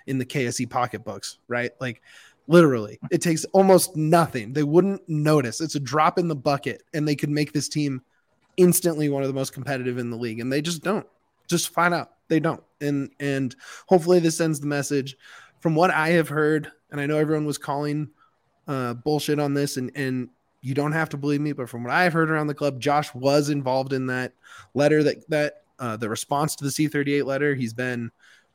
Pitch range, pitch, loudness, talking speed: 130-155 Hz, 145 Hz, -23 LUFS, 210 wpm